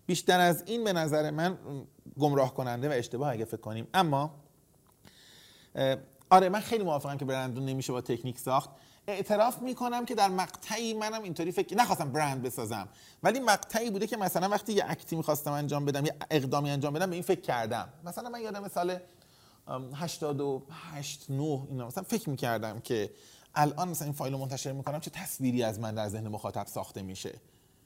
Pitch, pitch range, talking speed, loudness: 150 Hz, 135-185 Hz, 175 wpm, -31 LUFS